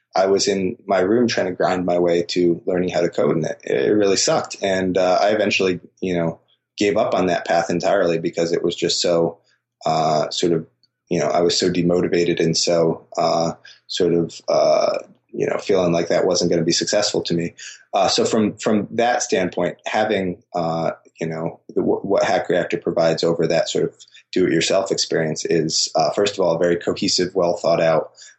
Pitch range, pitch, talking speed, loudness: 85-90 Hz, 85 Hz, 205 wpm, -19 LUFS